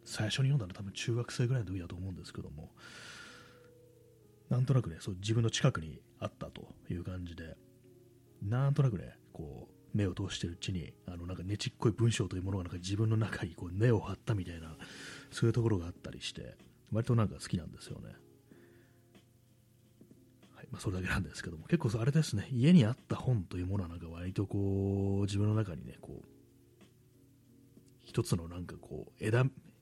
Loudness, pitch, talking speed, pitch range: -34 LUFS, 110 Hz, 385 characters per minute, 95-120 Hz